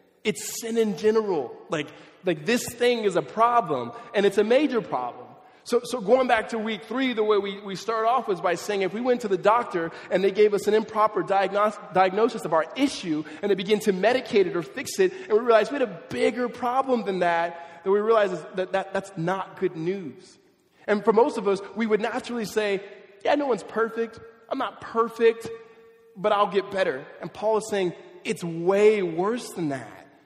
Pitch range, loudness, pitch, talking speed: 195-230 Hz, -25 LUFS, 215 Hz, 210 wpm